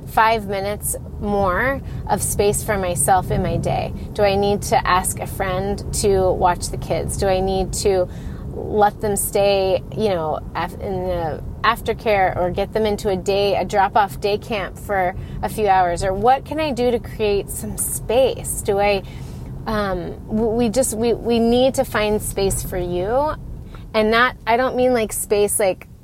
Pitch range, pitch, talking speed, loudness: 190-225 Hz, 205 Hz, 180 wpm, -20 LUFS